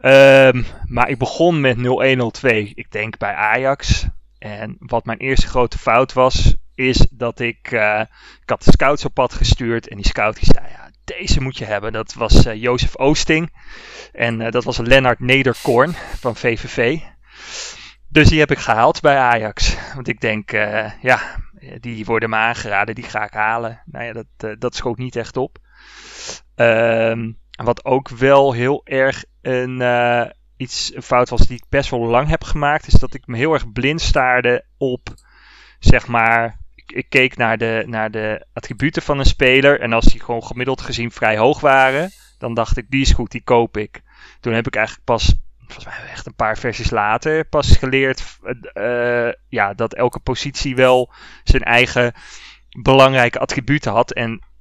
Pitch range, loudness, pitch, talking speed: 115-130 Hz, -17 LUFS, 120 Hz, 180 wpm